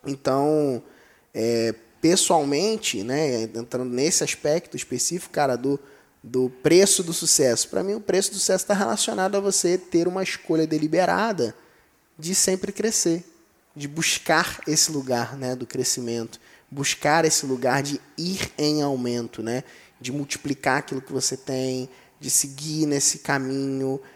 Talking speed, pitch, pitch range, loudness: 140 wpm, 140 Hz, 130-175 Hz, -23 LUFS